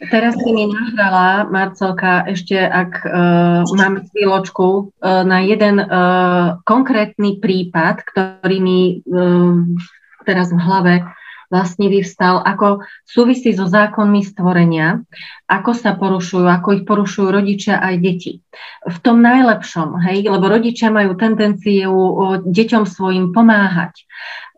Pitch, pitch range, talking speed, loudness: 190 Hz, 180-210 Hz, 120 wpm, -14 LUFS